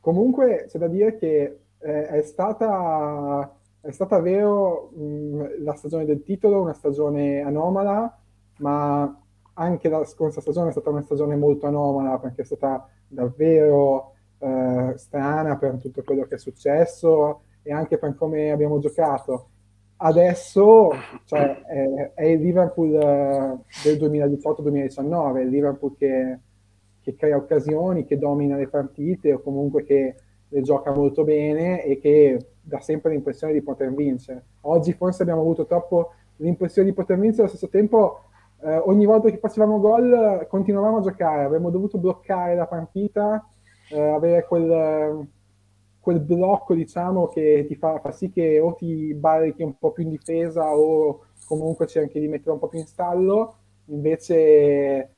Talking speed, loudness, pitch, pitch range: 150 wpm, -21 LUFS, 150 Hz, 140-170 Hz